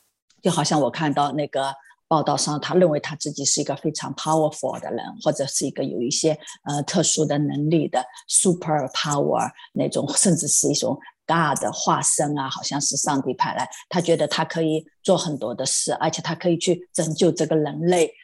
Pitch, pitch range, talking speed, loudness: 155 Hz, 145-165 Hz, 330 characters per minute, -22 LUFS